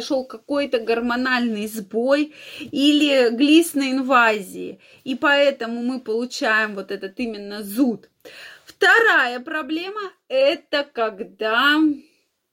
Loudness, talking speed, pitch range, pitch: -20 LUFS, 85 wpm, 230-290 Hz, 260 Hz